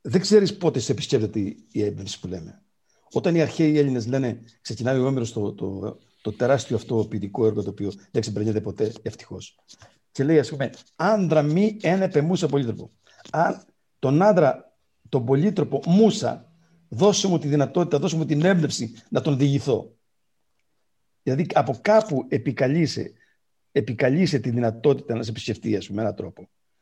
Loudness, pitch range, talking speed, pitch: -23 LUFS, 110-160 Hz, 155 wpm, 135 Hz